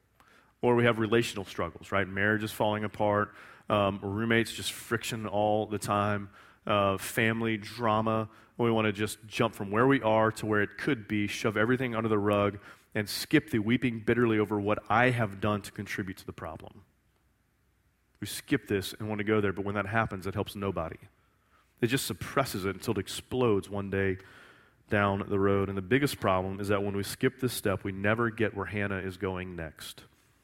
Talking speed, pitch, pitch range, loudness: 195 wpm, 105 Hz, 100-115 Hz, -30 LUFS